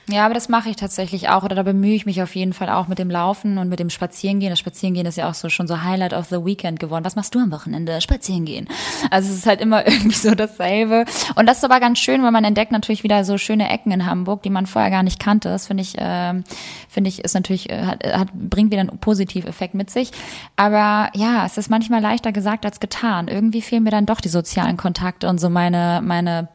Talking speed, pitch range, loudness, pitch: 250 wpm, 185-215 Hz, -19 LUFS, 195 Hz